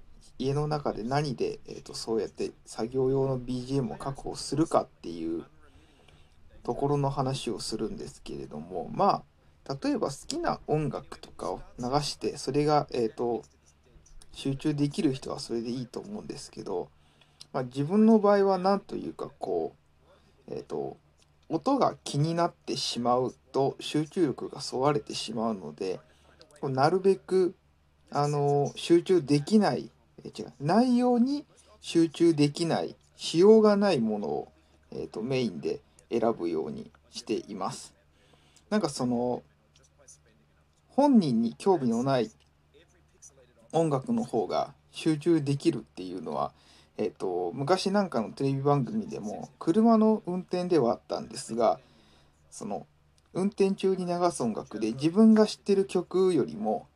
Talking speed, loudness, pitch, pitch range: 265 characters per minute, -28 LUFS, 145 Hz, 115-195 Hz